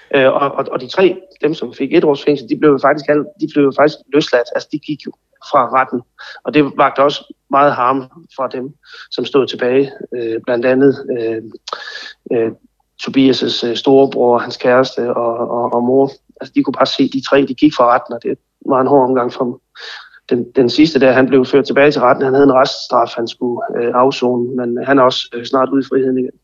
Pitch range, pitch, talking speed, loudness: 125-140 Hz, 130 Hz, 205 wpm, -14 LUFS